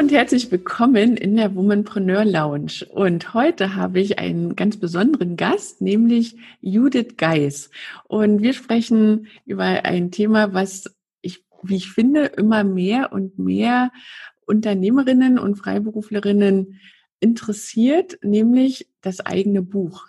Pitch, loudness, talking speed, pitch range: 210 Hz, -19 LUFS, 120 wpm, 190-235 Hz